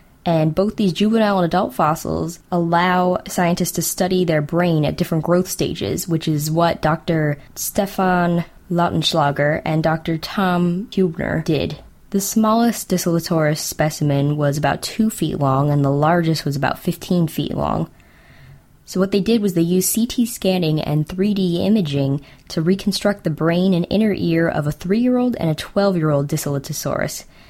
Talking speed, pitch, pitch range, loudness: 155 wpm, 170 Hz, 155-190 Hz, -19 LUFS